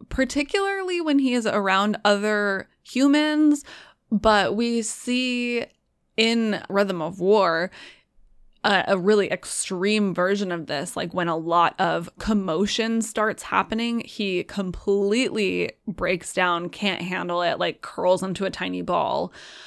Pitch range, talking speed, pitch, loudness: 180-230 Hz, 130 wpm, 205 Hz, -23 LUFS